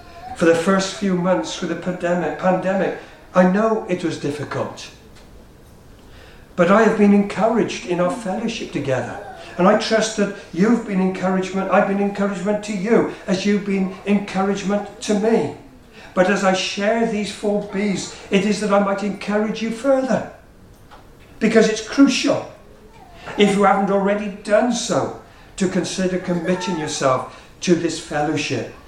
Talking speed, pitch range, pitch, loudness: 150 wpm, 180-210 Hz, 195 Hz, -19 LUFS